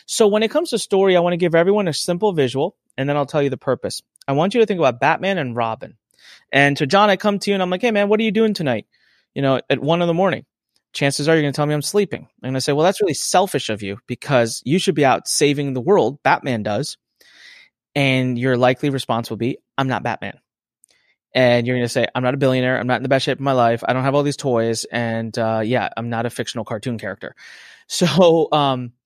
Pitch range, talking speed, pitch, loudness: 125-180 Hz, 265 wpm, 140 Hz, -19 LUFS